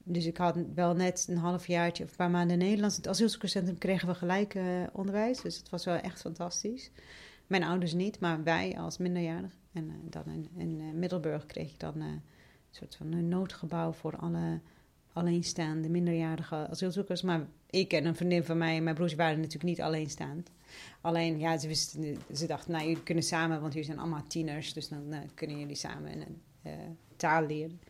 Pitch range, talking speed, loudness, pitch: 160-180 Hz, 195 wpm, -33 LUFS, 170 Hz